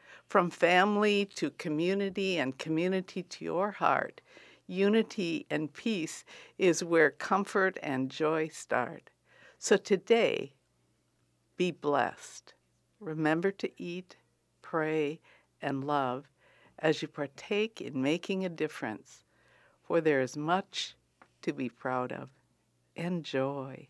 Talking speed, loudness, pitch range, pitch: 110 wpm, -31 LUFS, 140-190 Hz, 160 Hz